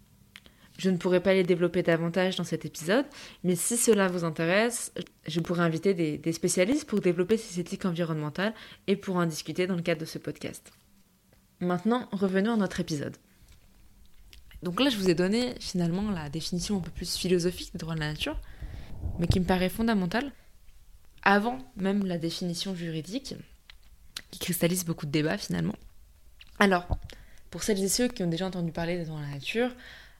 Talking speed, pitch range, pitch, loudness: 180 wpm, 165-200 Hz, 180 Hz, -29 LUFS